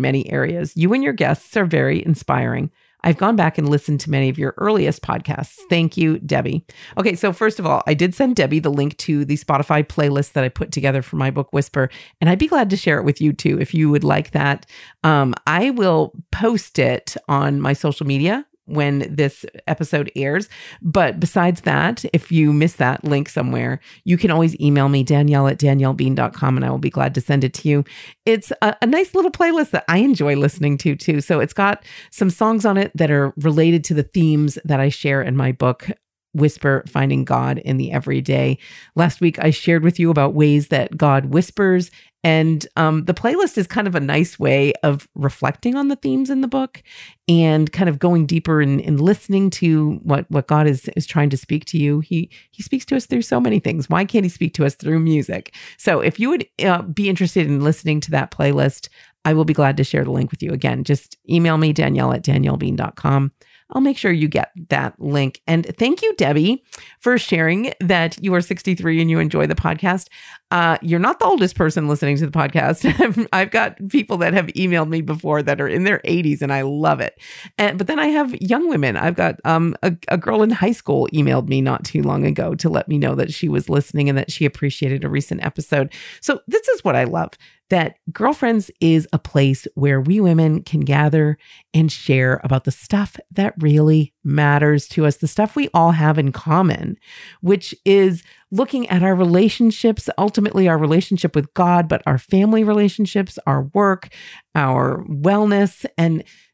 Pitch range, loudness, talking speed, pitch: 145-190 Hz, -18 LUFS, 210 wpm, 160 Hz